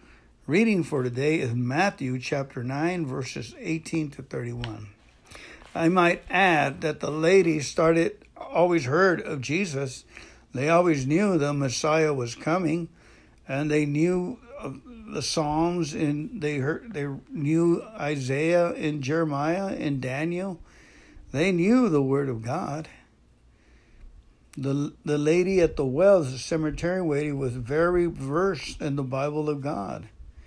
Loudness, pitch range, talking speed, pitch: -25 LUFS, 135-170 Hz, 130 wpm, 150 Hz